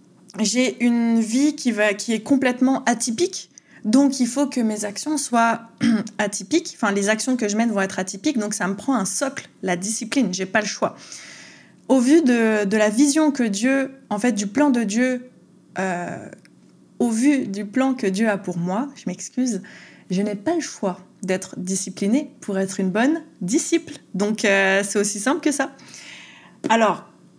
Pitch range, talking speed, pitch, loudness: 205-265 Hz, 185 wpm, 230 Hz, -21 LUFS